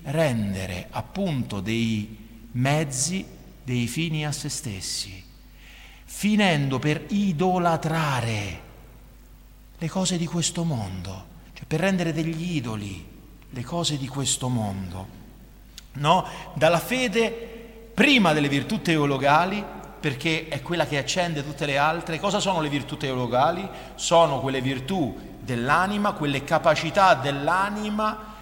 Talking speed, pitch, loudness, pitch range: 115 wpm, 150 Hz, -24 LUFS, 125-175 Hz